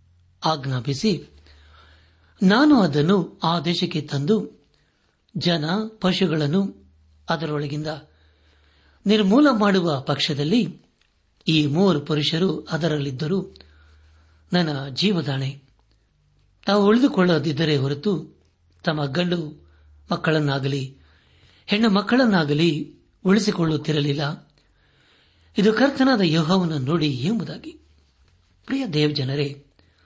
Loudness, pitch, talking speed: -21 LUFS, 150 Hz, 70 wpm